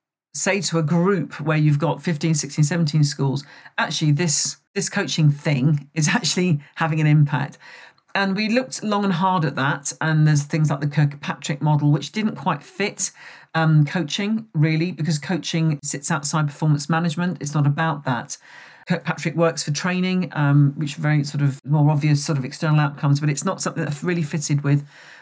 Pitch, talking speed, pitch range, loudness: 160 Hz, 185 wpm, 150-175 Hz, -21 LUFS